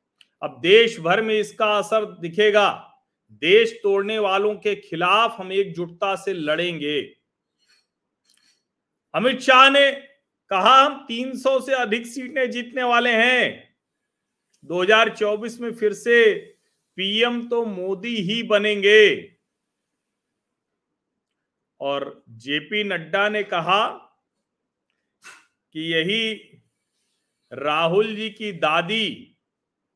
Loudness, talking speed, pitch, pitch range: -20 LUFS, 95 wpm, 215 Hz, 195-250 Hz